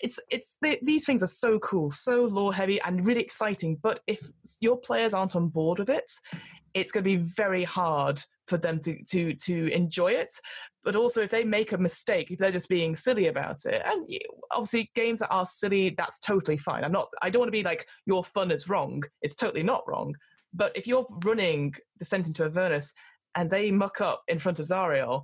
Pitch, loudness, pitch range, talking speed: 190 Hz, -28 LUFS, 175-225 Hz, 215 wpm